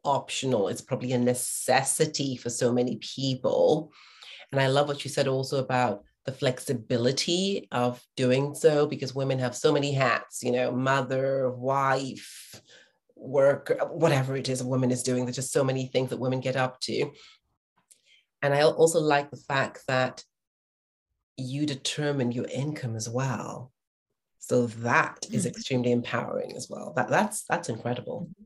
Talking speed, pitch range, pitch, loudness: 155 wpm, 125-140 Hz, 130 Hz, -27 LUFS